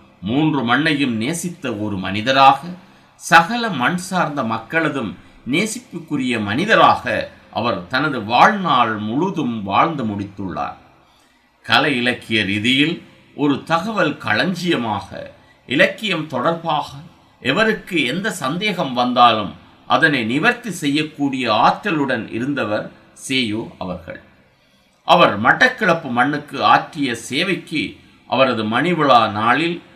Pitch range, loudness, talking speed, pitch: 110-170 Hz, -17 LUFS, 90 wpm, 135 Hz